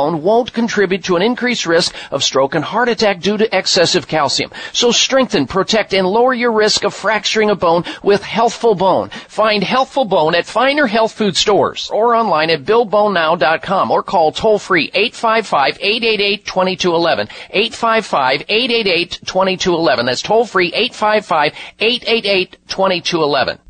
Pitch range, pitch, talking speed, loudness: 180-225 Hz, 205 Hz, 125 wpm, -14 LUFS